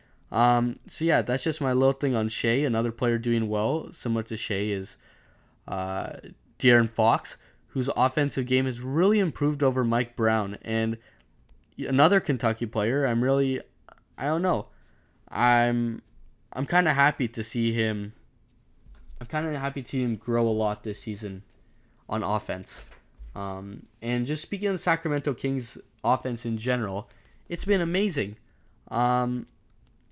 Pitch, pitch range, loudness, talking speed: 120 Hz, 110-135 Hz, -26 LUFS, 150 wpm